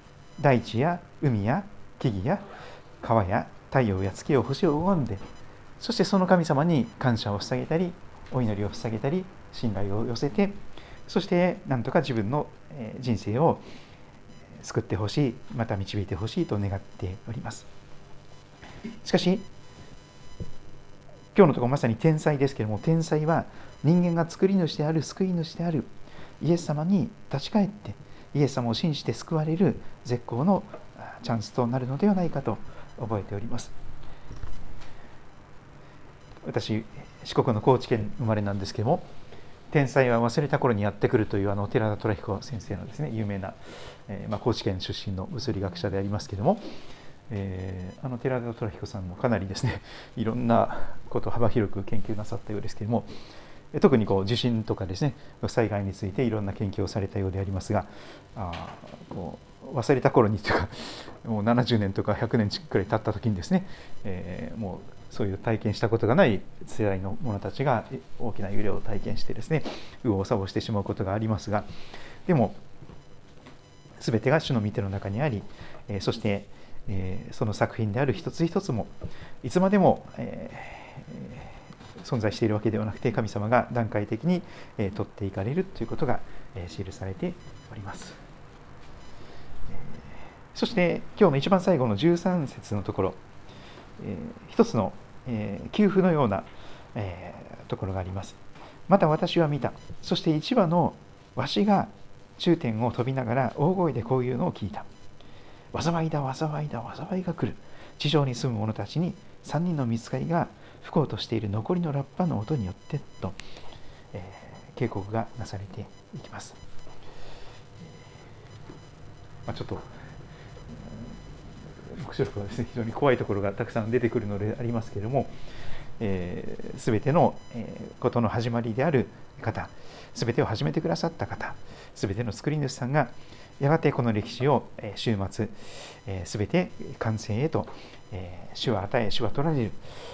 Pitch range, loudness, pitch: 105-145 Hz, -28 LUFS, 120 Hz